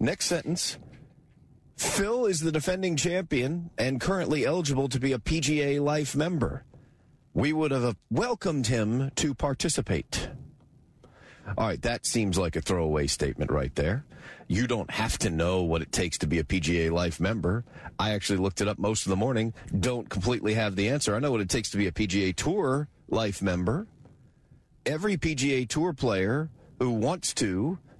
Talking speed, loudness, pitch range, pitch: 170 wpm, -28 LUFS, 100-150 Hz, 125 Hz